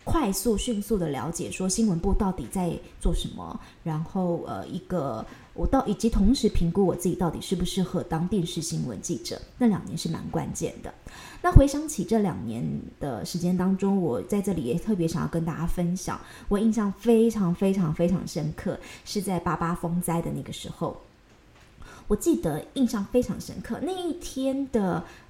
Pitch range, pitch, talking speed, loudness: 170-215 Hz, 185 Hz, 275 characters per minute, -27 LUFS